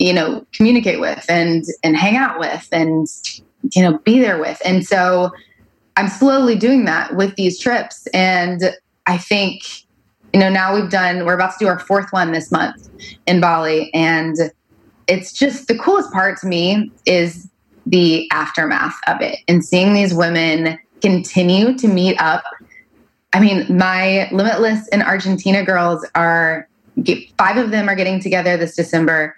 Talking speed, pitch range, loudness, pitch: 165 wpm, 170-205 Hz, -15 LUFS, 185 Hz